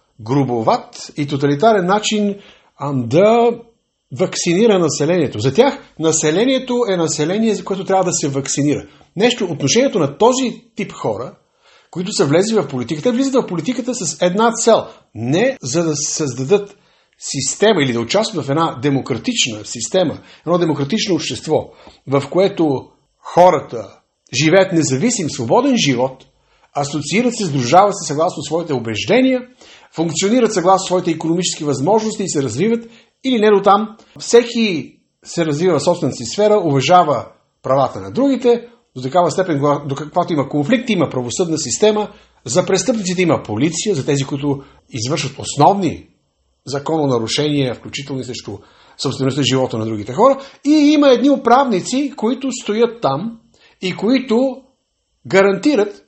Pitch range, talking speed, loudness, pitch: 145-225 Hz, 135 wpm, -16 LUFS, 180 Hz